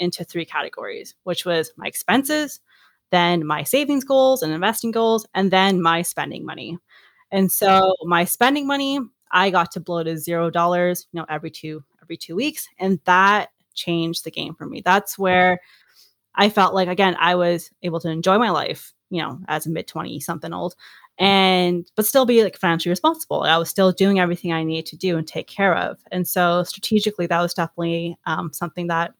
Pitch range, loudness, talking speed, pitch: 170-195 Hz, -20 LUFS, 195 wpm, 180 Hz